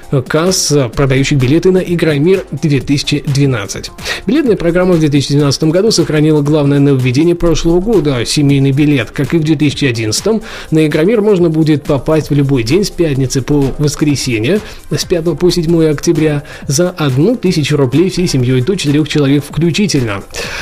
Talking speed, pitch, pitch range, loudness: 140 wpm, 150 Hz, 140-170 Hz, -12 LUFS